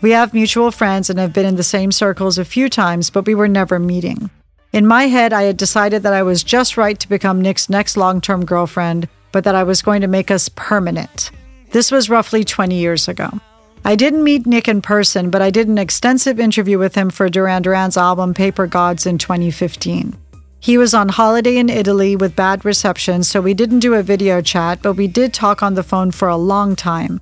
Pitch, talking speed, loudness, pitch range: 195 Hz, 225 wpm, -14 LUFS, 185-215 Hz